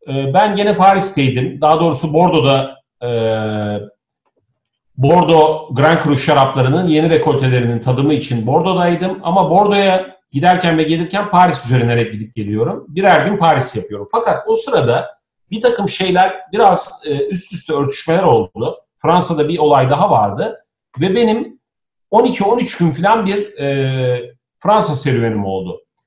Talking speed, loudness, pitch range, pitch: 120 wpm, -14 LUFS, 130-190 Hz, 155 Hz